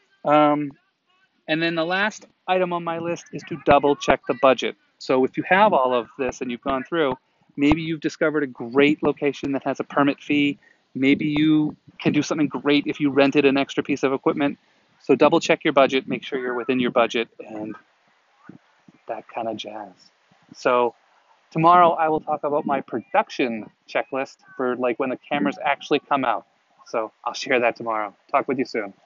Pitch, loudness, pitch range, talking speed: 145 Hz, -22 LUFS, 130-155 Hz, 190 wpm